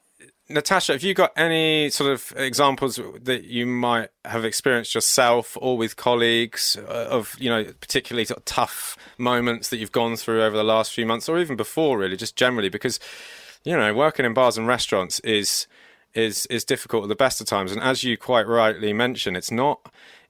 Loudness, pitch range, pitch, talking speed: -22 LUFS, 115-130 Hz, 120 Hz, 185 wpm